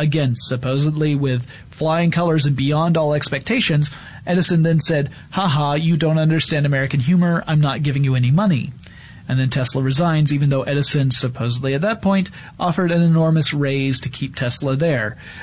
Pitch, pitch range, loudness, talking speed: 150 Hz, 135-165 Hz, -18 LUFS, 165 wpm